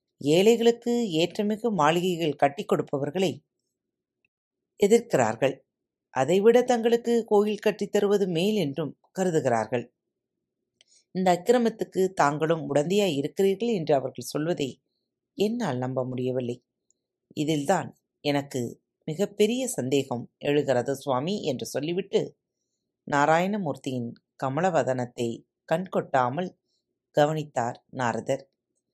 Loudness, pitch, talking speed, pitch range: -26 LUFS, 160 Hz, 80 wpm, 135-205 Hz